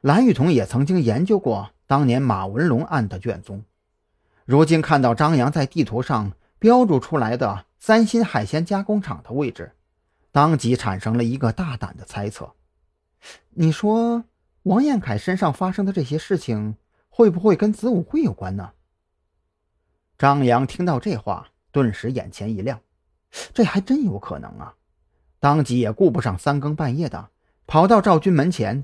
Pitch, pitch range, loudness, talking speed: 130 Hz, 100-170 Hz, -20 LUFS, 240 characters per minute